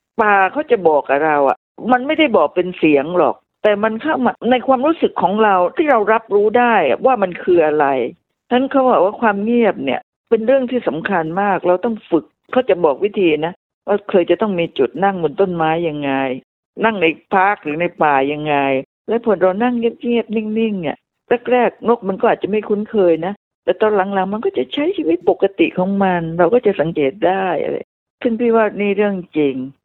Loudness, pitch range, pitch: -16 LUFS, 175-235 Hz, 200 Hz